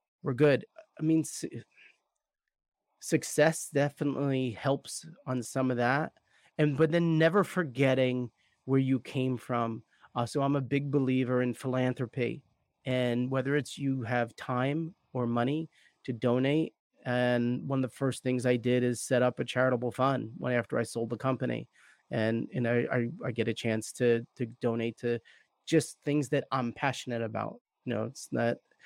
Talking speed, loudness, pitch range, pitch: 170 wpm, -31 LUFS, 120-140 Hz, 130 Hz